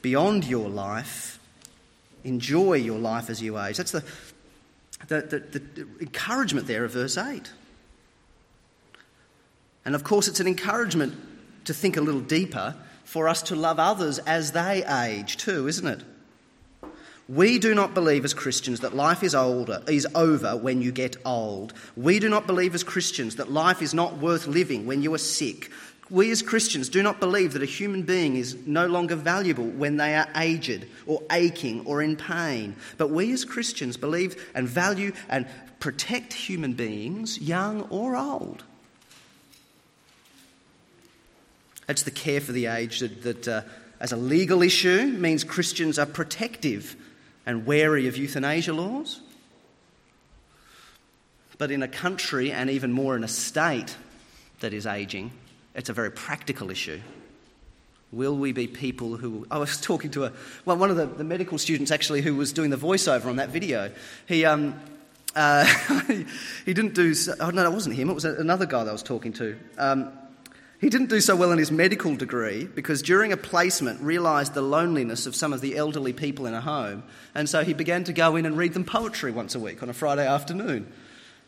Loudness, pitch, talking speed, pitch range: -25 LUFS, 155 Hz, 180 wpm, 130-180 Hz